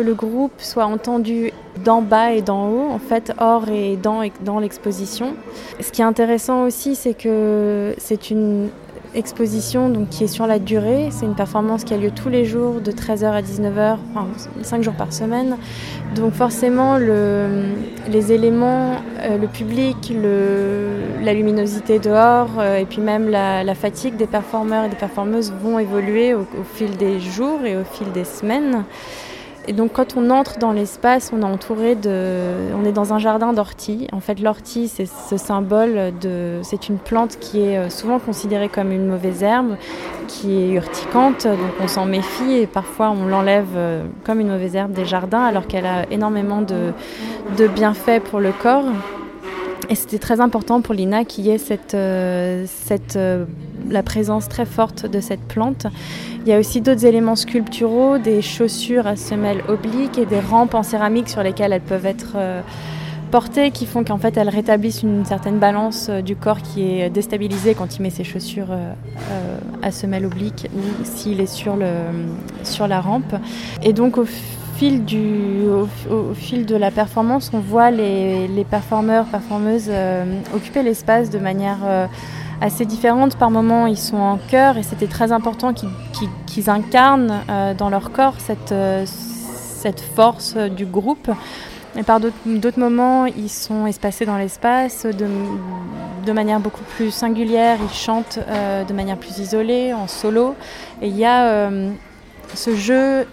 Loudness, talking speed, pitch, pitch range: -19 LUFS, 180 wpm, 215 Hz, 200-230 Hz